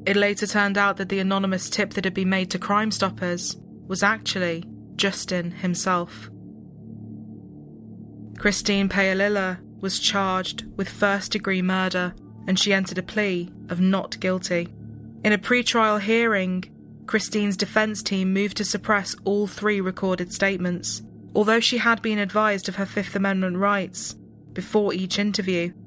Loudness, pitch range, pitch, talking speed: -23 LUFS, 185-205 Hz, 195 Hz, 140 wpm